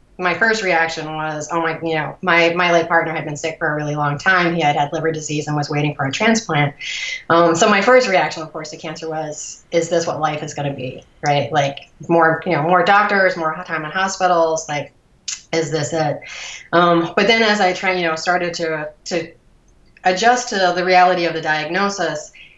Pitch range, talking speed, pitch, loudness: 155-180 Hz, 220 wpm, 165 Hz, -17 LUFS